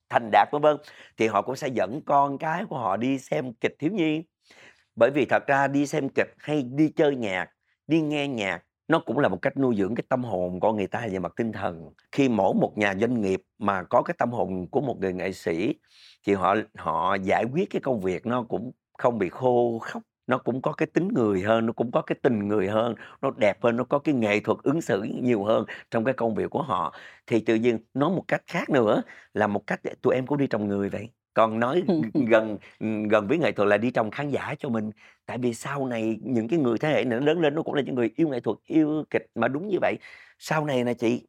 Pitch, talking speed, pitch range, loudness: 115 Hz, 250 wpm, 105-140 Hz, -25 LUFS